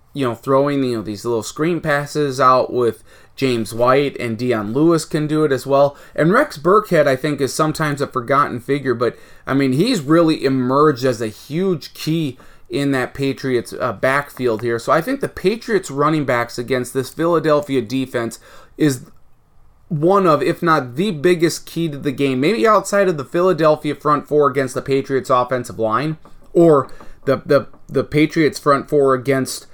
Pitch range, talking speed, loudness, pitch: 130-155 Hz, 180 wpm, -17 LUFS, 140 Hz